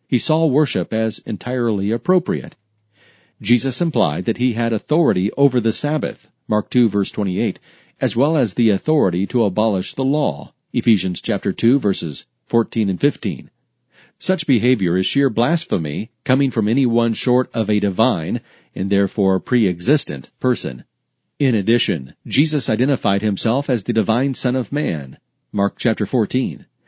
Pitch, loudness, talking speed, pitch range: 115 Hz, -19 LUFS, 145 wpm, 105-135 Hz